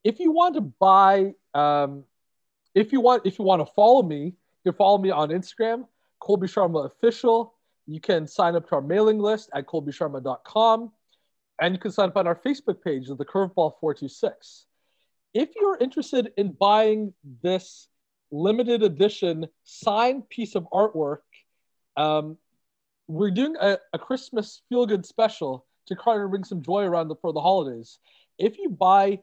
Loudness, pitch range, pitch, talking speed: -23 LUFS, 160-220 Hz, 195 Hz, 170 wpm